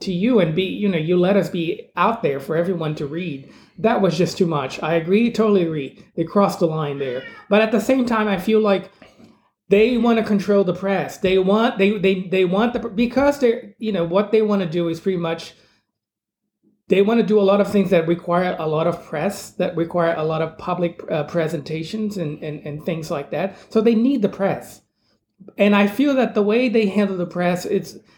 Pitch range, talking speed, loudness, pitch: 165-210 Hz, 230 wpm, -20 LUFS, 190 Hz